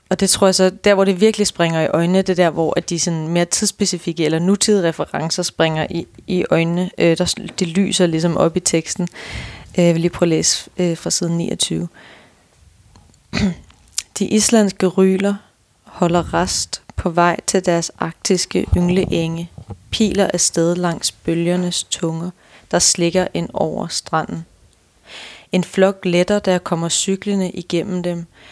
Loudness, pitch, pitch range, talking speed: -17 LUFS, 175 Hz, 165-190 Hz, 160 wpm